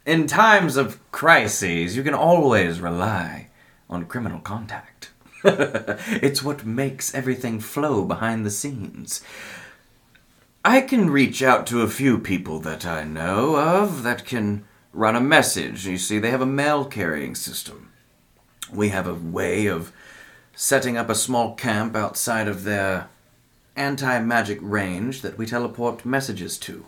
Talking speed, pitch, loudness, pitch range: 145 wpm, 115 Hz, -21 LUFS, 100-135 Hz